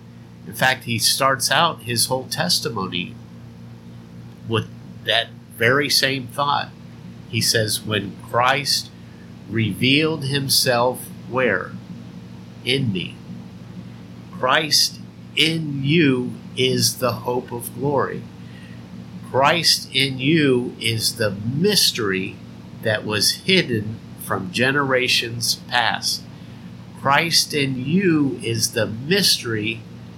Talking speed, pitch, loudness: 95 wpm, 110 Hz, -19 LUFS